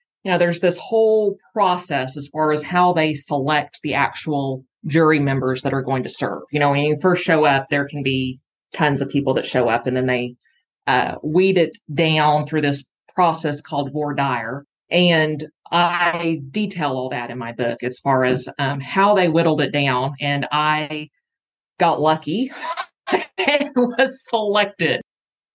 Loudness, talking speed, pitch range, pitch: -19 LUFS, 175 wpm, 140-175 Hz, 150 Hz